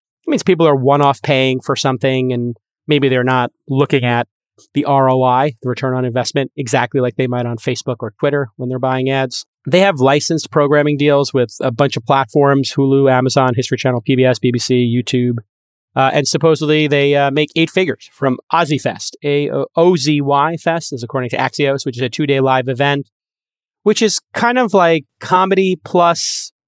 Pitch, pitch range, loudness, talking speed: 135 Hz, 130-150 Hz, -15 LUFS, 185 wpm